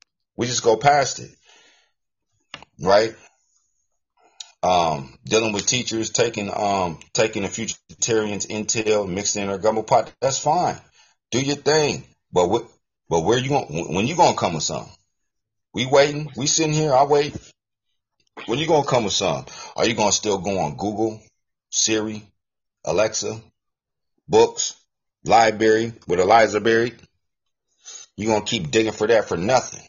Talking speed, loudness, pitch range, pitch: 150 wpm, -20 LUFS, 105-125 Hz, 110 Hz